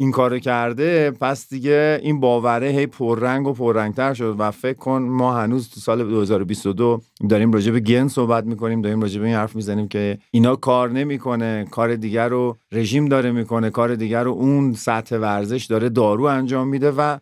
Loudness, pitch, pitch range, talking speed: -19 LUFS, 120 Hz, 110-130 Hz, 185 wpm